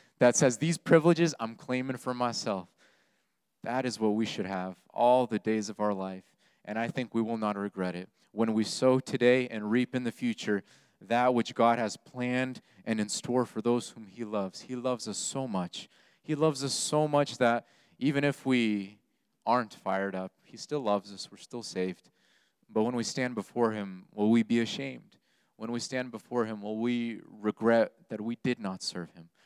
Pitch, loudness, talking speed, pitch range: 115 Hz, -30 LUFS, 200 wpm, 105-130 Hz